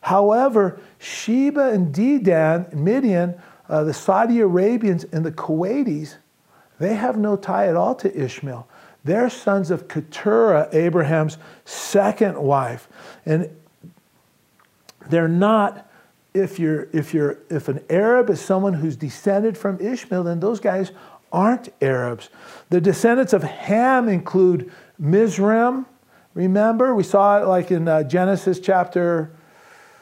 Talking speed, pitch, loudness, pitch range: 125 wpm, 185 Hz, -19 LUFS, 160-210 Hz